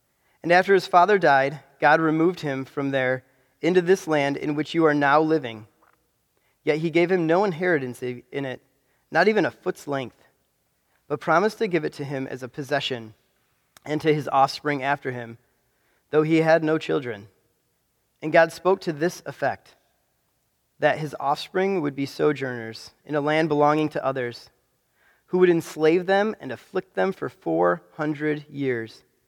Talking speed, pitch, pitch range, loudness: 170 wpm, 150 Hz, 130-165 Hz, -23 LUFS